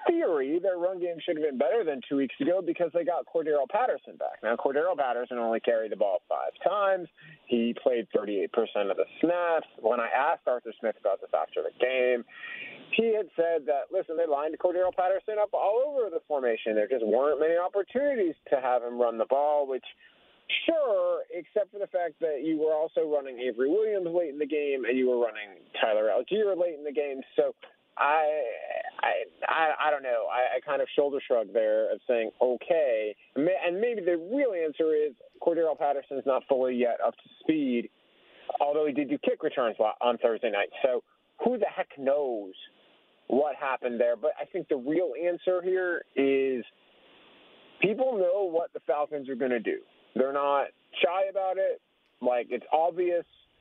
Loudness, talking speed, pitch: -28 LUFS, 190 wpm, 175 Hz